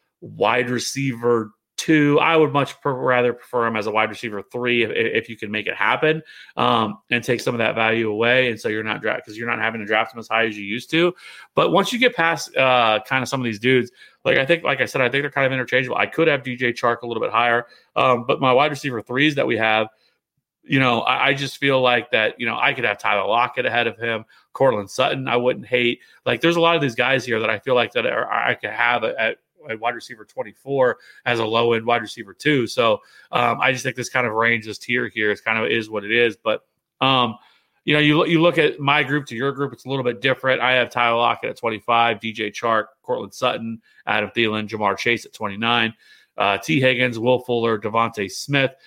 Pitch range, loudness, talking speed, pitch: 115-135 Hz, -20 LUFS, 250 wpm, 120 Hz